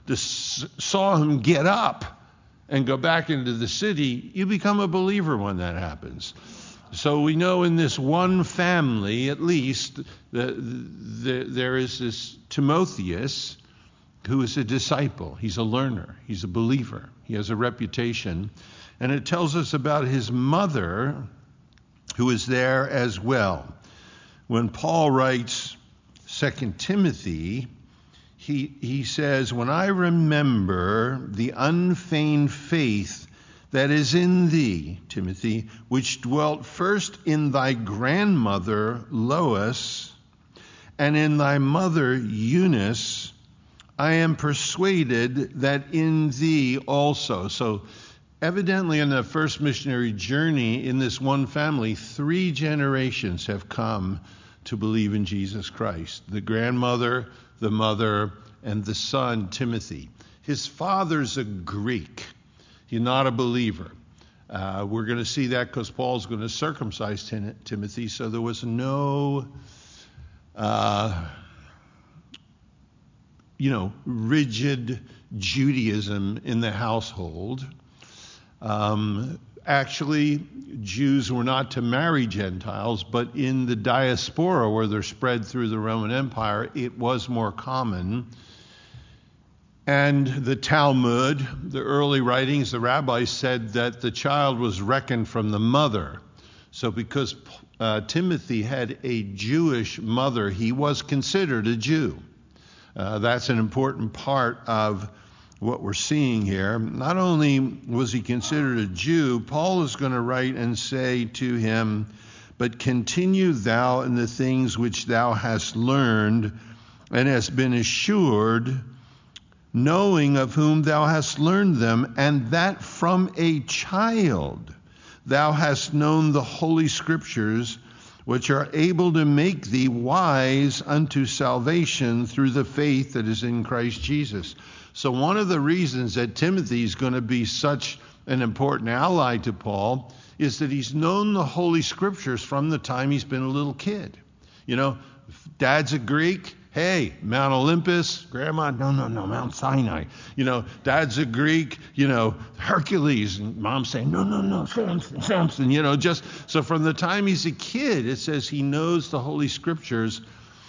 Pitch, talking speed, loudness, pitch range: 130 Hz, 135 wpm, -24 LUFS, 115-150 Hz